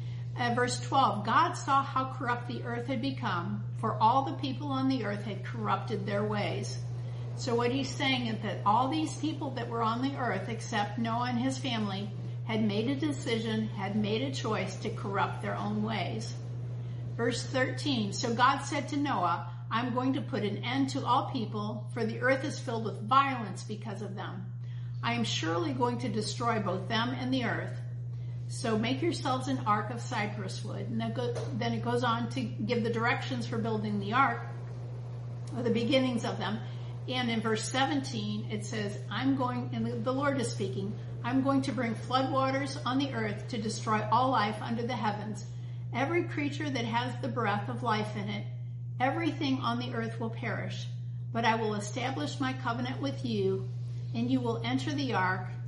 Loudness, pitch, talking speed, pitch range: -32 LUFS, 120 Hz, 190 wpm, 115-125 Hz